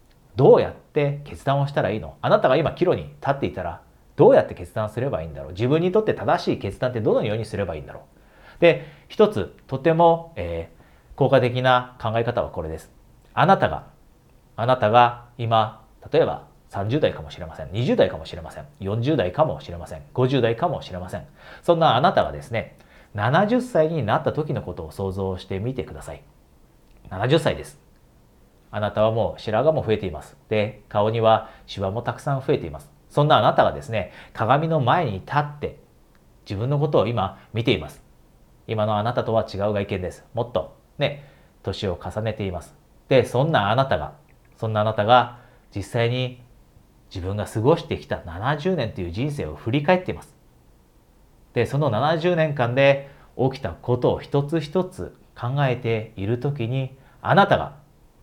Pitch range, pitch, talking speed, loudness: 95-140 Hz, 115 Hz, 335 characters per minute, -22 LUFS